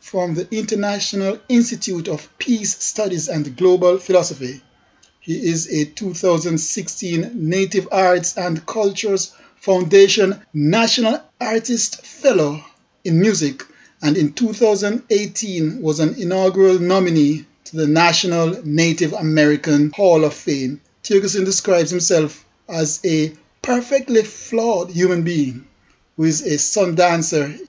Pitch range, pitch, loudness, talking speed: 155-205 Hz, 180 Hz, -17 LUFS, 115 wpm